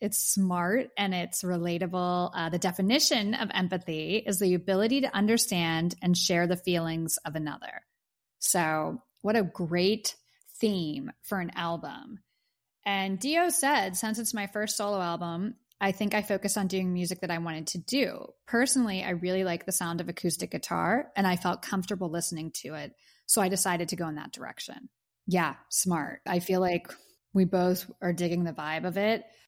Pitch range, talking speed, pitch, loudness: 175-210 Hz, 175 wpm, 185 Hz, -29 LUFS